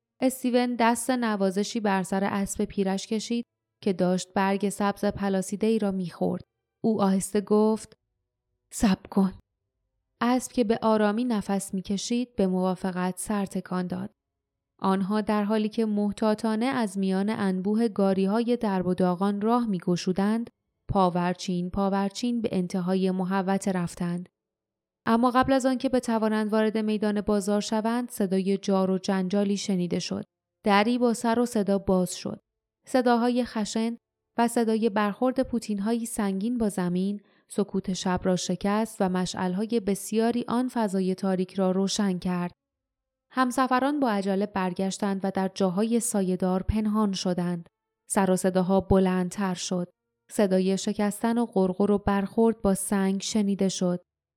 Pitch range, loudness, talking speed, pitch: 190-225 Hz, -26 LUFS, 135 wpm, 200 Hz